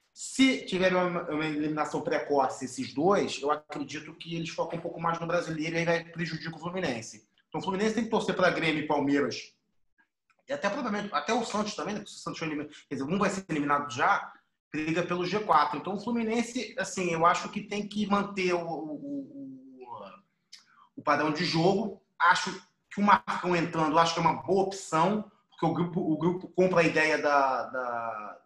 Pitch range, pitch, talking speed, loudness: 155-200 Hz, 175 Hz, 190 wpm, -29 LUFS